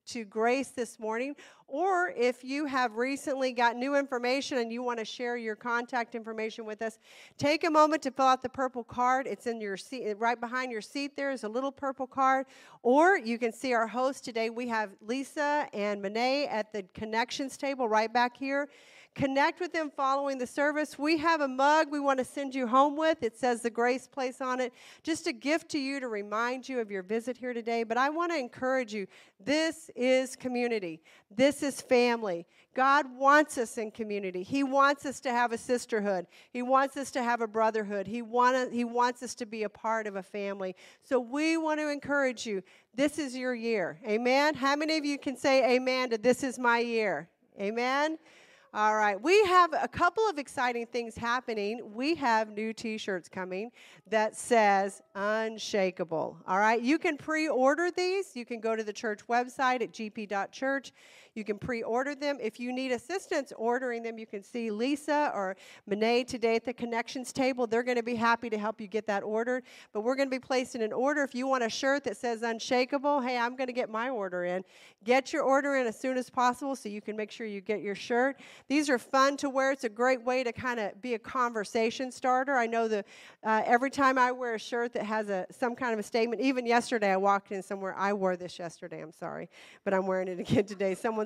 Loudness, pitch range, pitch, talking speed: -30 LUFS, 220-270 Hz, 245 Hz, 215 wpm